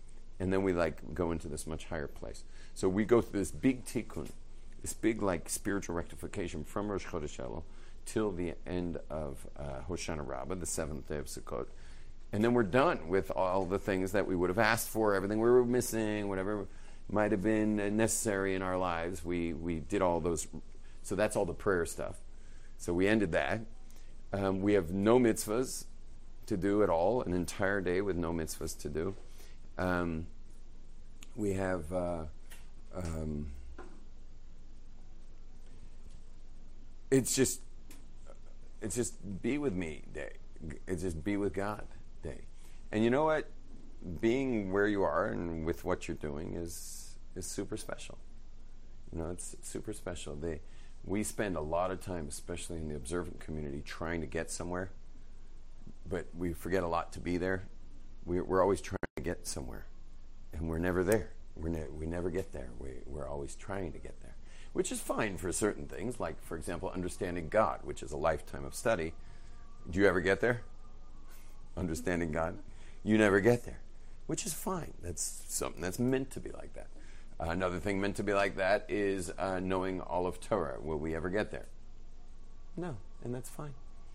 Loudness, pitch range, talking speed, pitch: -34 LUFS, 80-105 Hz, 175 wpm, 90 Hz